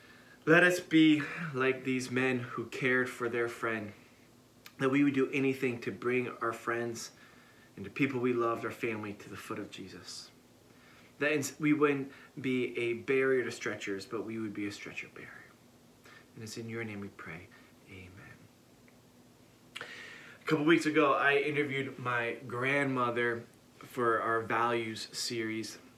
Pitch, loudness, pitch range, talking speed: 125 Hz, -31 LUFS, 115-135 Hz, 155 wpm